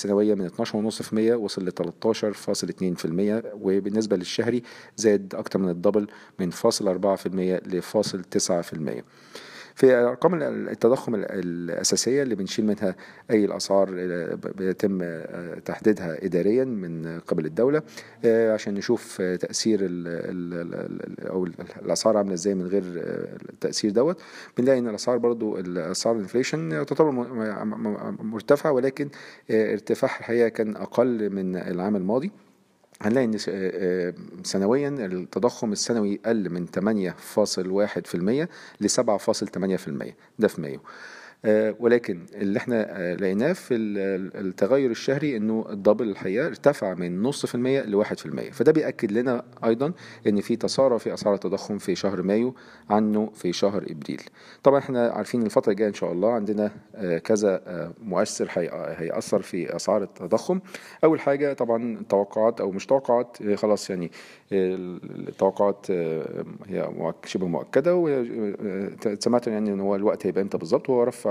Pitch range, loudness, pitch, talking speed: 95-120 Hz, -25 LUFS, 105 Hz, 120 wpm